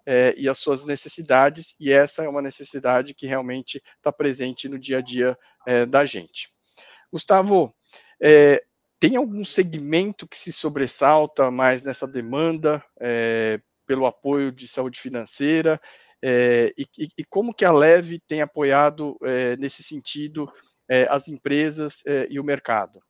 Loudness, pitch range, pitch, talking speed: -21 LUFS, 130-155 Hz, 140 Hz, 150 wpm